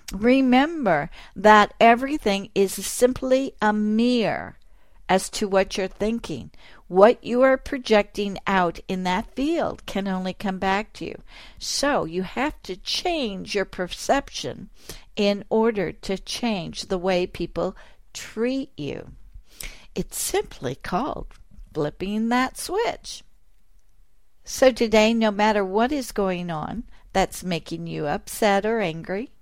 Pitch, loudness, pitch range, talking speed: 210 Hz, -23 LUFS, 190-245 Hz, 125 wpm